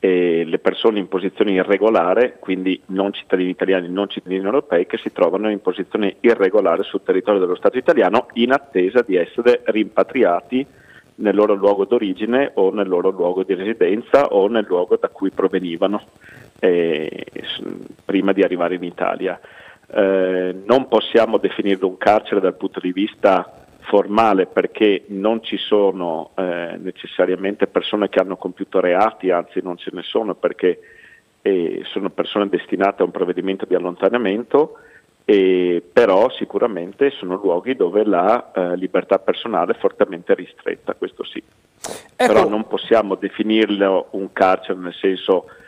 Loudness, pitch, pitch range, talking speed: -18 LUFS, 100 Hz, 95-140 Hz, 145 wpm